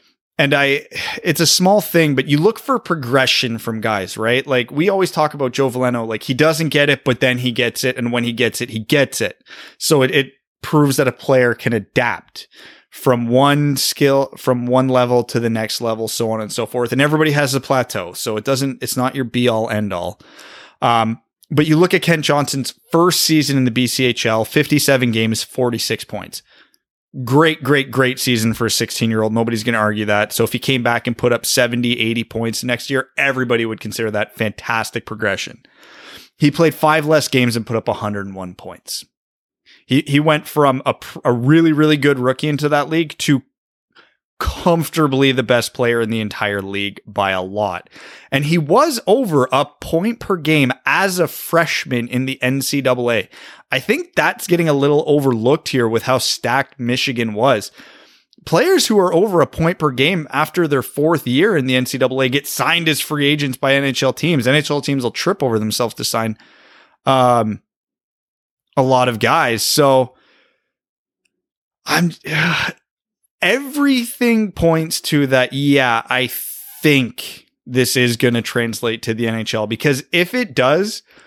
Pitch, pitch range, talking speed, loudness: 130 Hz, 115-150 Hz, 180 wpm, -16 LUFS